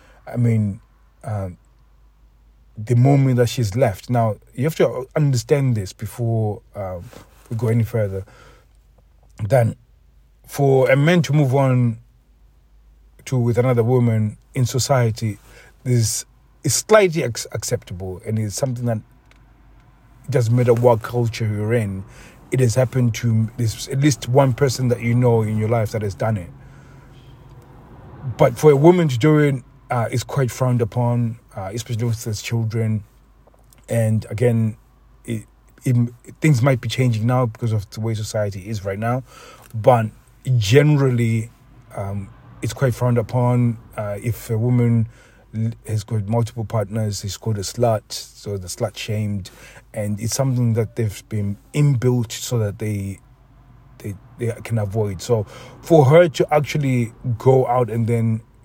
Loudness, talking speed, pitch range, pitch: -20 LUFS, 150 wpm, 110-125 Hz, 120 Hz